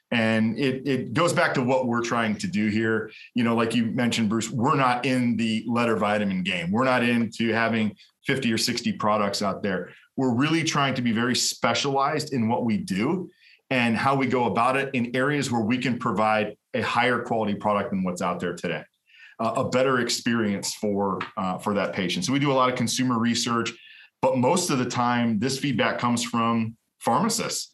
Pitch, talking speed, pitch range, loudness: 120 Hz, 205 wpm, 110-130 Hz, -24 LUFS